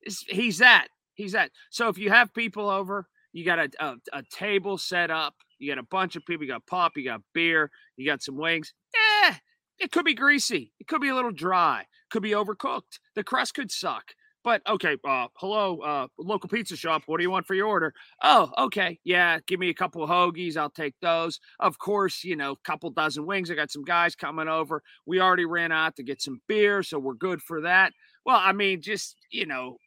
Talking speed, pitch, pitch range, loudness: 225 wpm, 185 Hz, 160-215 Hz, -25 LUFS